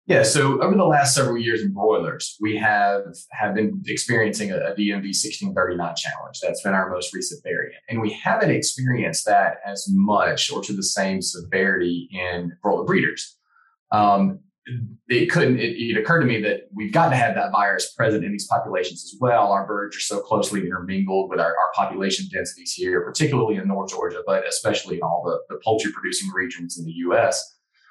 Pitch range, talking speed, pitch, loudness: 95-150 Hz, 195 wpm, 105 Hz, -22 LUFS